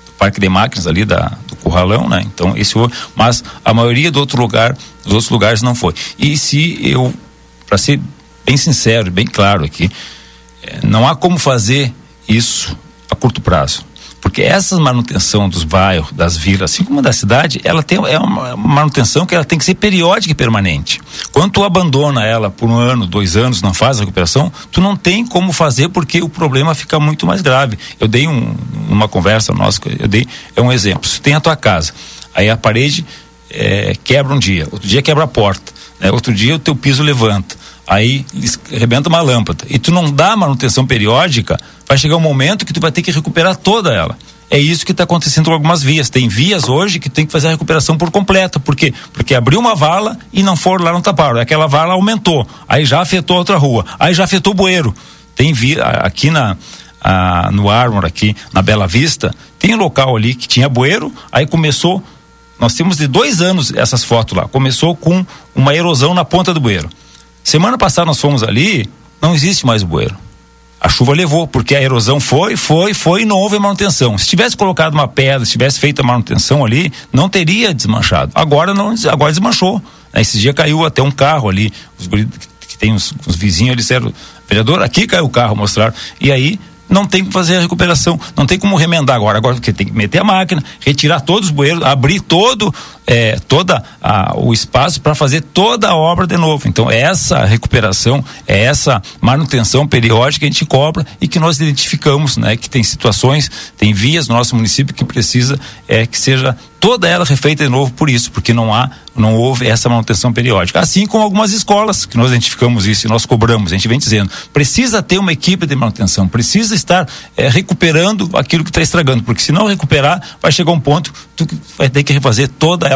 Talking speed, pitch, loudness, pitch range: 205 wpm, 140 Hz, -11 LUFS, 115-165 Hz